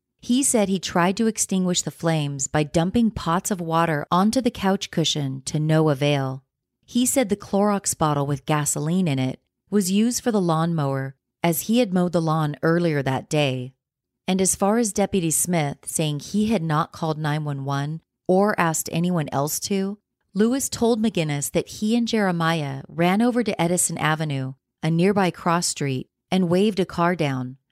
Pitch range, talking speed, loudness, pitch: 145-195 Hz, 175 wpm, -22 LUFS, 165 Hz